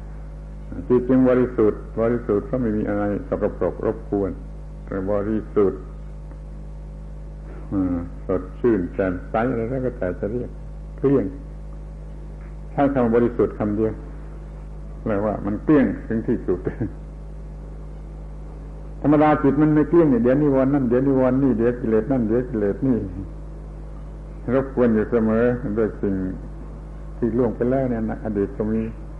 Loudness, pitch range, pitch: -21 LUFS, 110-150 Hz, 125 Hz